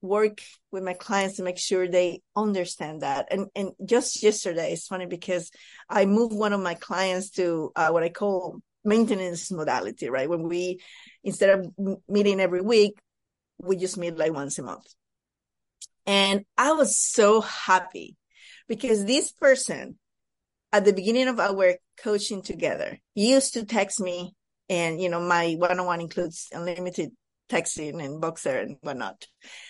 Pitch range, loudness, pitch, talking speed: 180-210 Hz, -25 LUFS, 190 Hz, 160 wpm